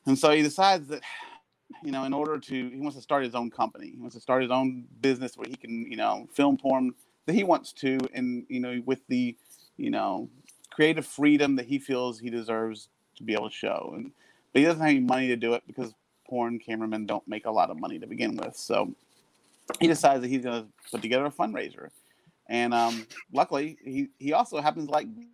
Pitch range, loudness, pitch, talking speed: 125-155 Hz, -28 LUFS, 135 Hz, 225 wpm